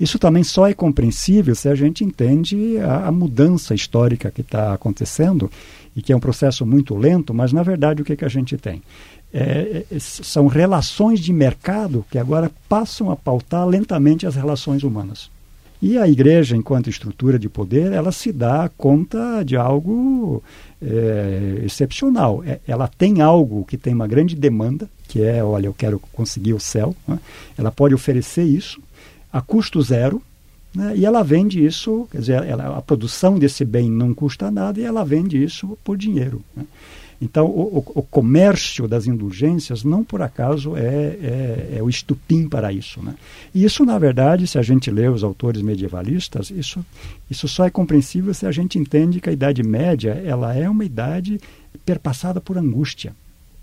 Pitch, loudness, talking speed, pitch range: 145 Hz, -18 LUFS, 175 wpm, 120-175 Hz